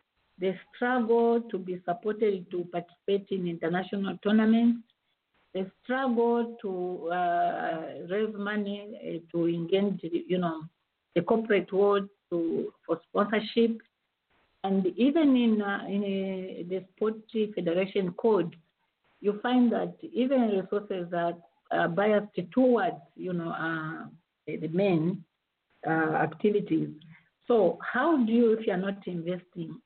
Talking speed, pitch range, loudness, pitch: 125 wpm, 175-220 Hz, -29 LUFS, 195 Hz